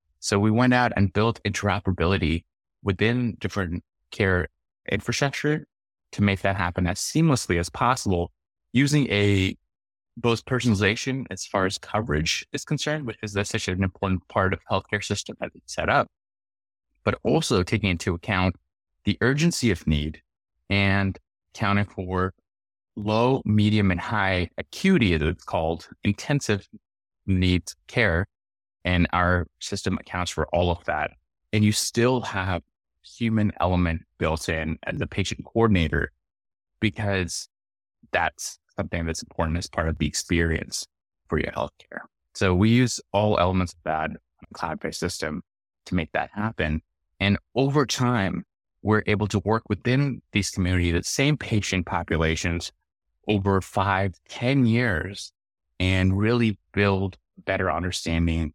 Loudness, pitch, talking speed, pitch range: -25 LUFS, 100 Hz, 140 wpm, 90-110 Hz